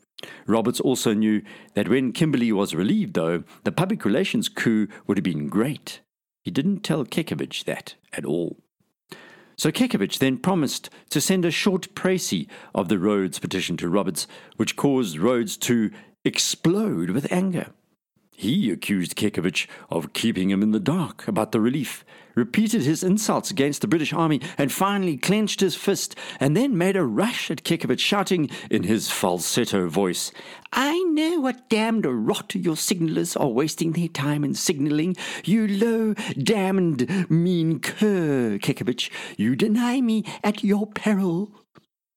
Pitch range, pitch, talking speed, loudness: 125-205 Hz, 175 Hz, 150 wpm, -23 LUFS